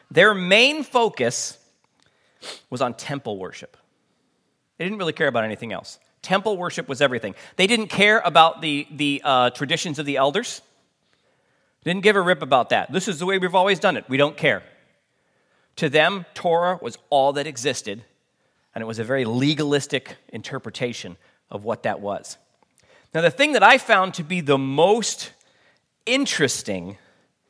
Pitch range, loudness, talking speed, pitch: 140-195 Hz, -20 LUFS, 165 wpm, 160 Hz